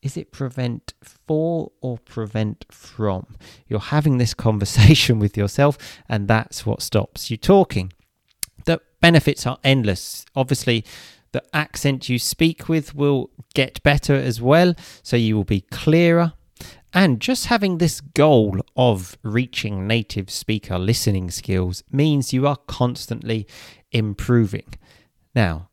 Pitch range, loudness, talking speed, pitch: 110-145 Hz, -20 LUFS, 130 wpm, 125 Hz